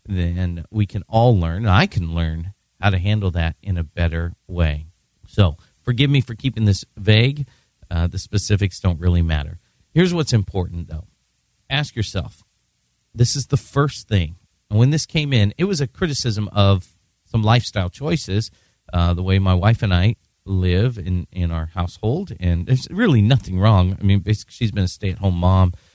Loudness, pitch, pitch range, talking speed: -20 LUFS, 100 Hz, 90-115 Hz, 180 wpm